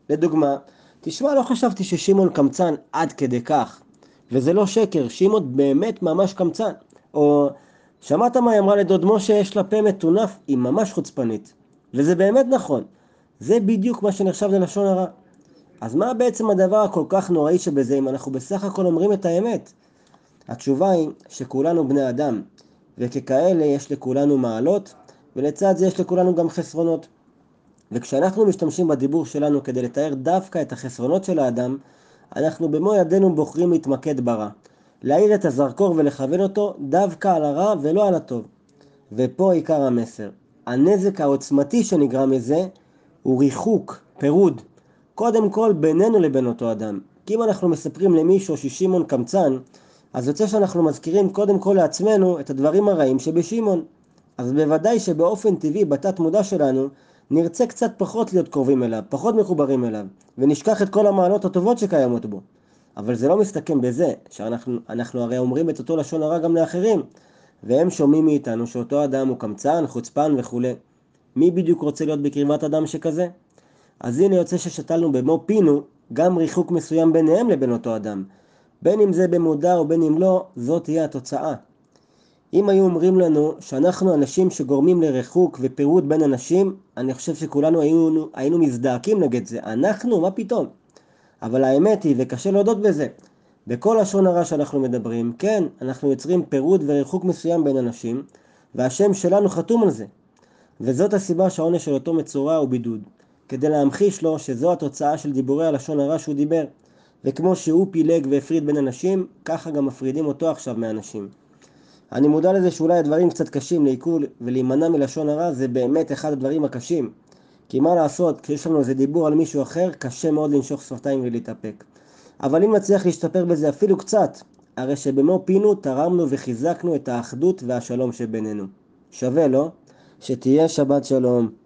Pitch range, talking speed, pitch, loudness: 135-185 Hz, 155 wpm, 160 Hz, -20 LUFS